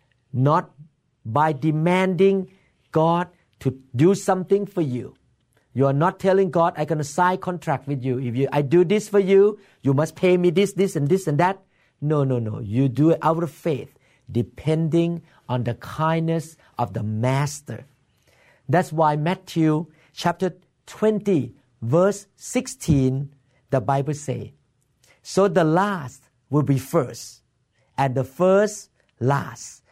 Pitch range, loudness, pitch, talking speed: 135-180 Hz, -22 LUFS, 155 Hz, 145 wpm